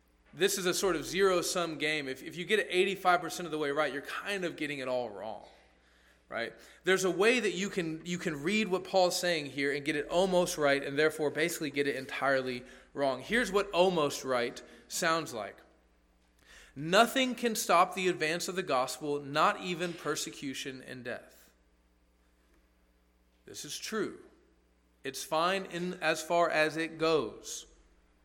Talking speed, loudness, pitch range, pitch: 170 wpm, -31 LUFS, 130-180 Hz, 155 Hz